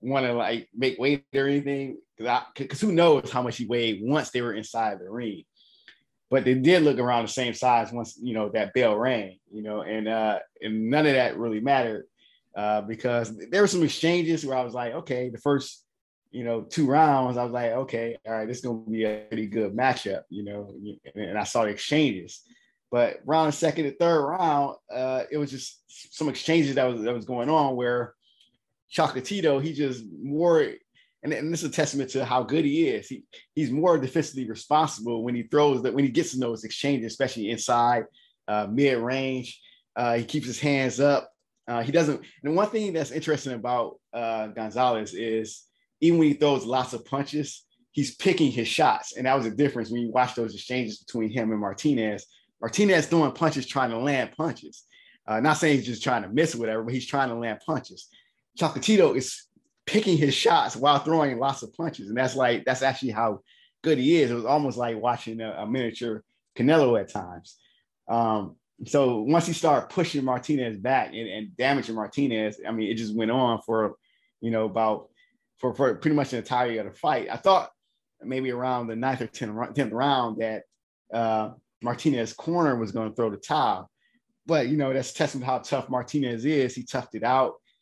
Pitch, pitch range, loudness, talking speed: 125 Hz, 115-145 Hz, -26 LUFS, 205 wpm